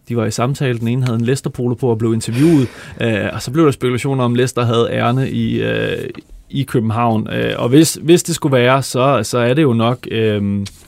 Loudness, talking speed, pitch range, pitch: -16 LUFS, 230 wpm, 115-135 Hz, 125 Hz